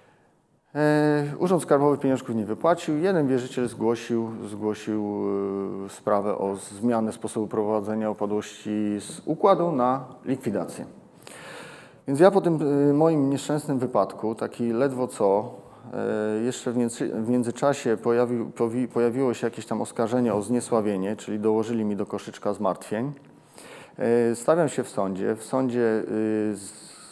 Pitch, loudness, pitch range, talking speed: 120 Hz, -25 LUFS, 110-135 Hz, 115 wpm